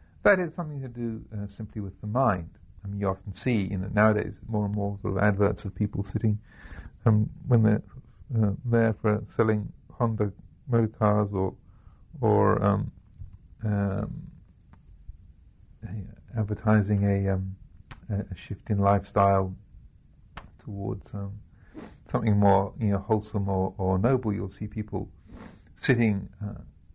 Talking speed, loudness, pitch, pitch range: 145 wpm, -27 LUFS, 105 Hz, 95-110 Hz